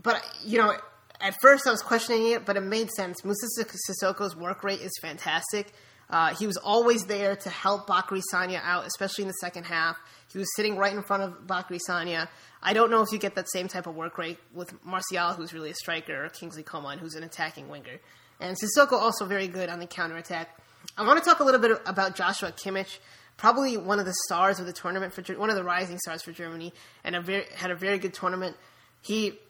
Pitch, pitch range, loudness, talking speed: 190 Hz, 175-205 Hz, -27 LUFS, 230 wpm